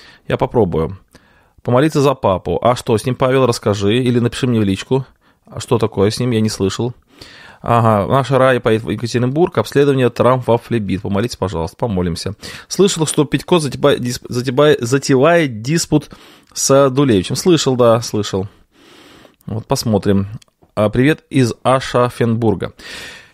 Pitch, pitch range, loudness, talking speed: 125 Hz, 105-135 Hz, -15 LUFS, 135 wpm